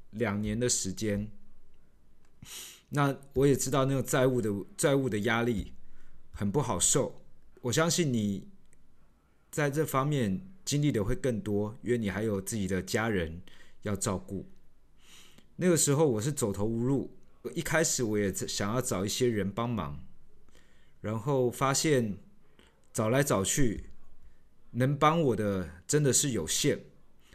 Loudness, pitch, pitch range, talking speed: -29 LUFS, 115 Hz, 95-135 Hz, 200 characters per minute